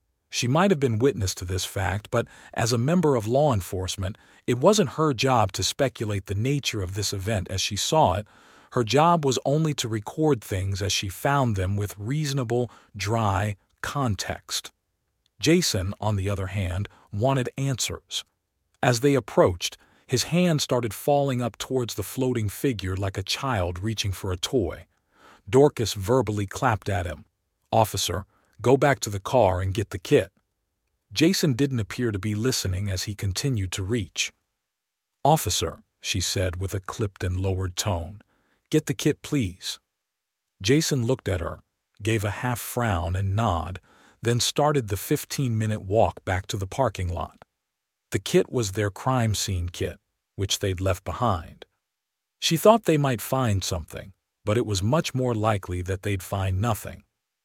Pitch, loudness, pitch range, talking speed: 105 Hz, -25 LUFS, 95-130 Hz, 165 wpm